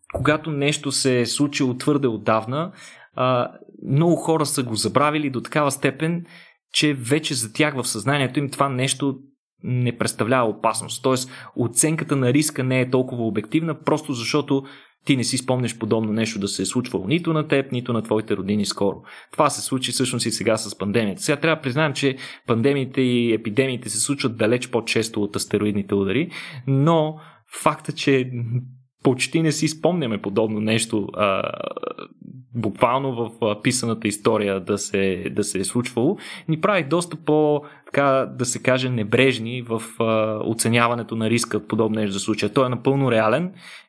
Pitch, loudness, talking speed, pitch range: 130 Hz, -22 LUFS, 165 wpm, 110-145 Hz